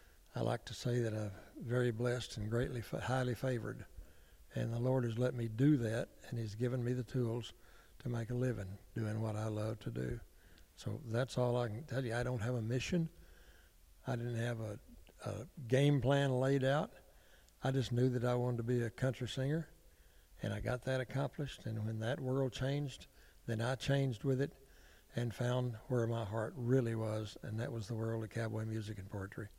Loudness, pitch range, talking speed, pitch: -38 LUFS, 110-130 Hz, 205 wpm, 120 Hz